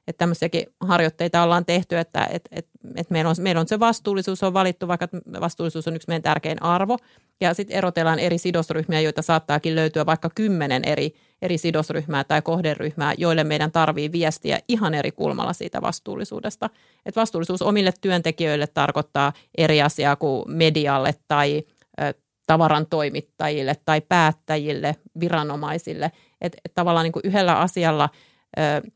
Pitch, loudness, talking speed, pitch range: 165 Hz, -22 LUFS, 145 wpm, 155-175 Hz